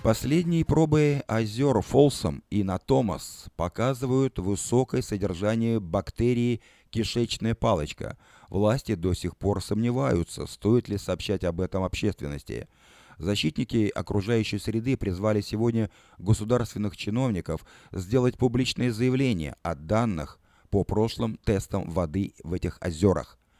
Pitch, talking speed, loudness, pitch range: 105 Hz, 105 wpm, -27 LUFS, 95-120 Hz